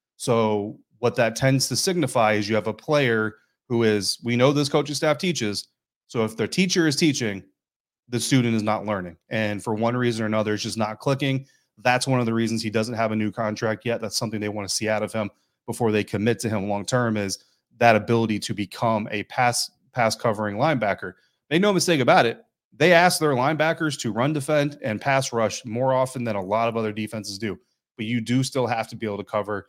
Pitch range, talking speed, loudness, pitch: 105-130 Hz, 225 wpm, -23 LUFS, 115 Hz